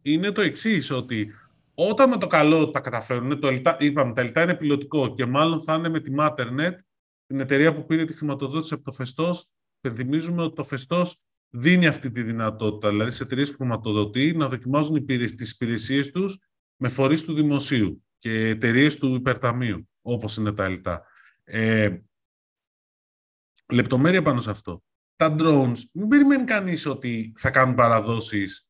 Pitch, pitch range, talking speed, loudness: 135 Hz, 115-155 Hz, 160 wpm, -23 LUFS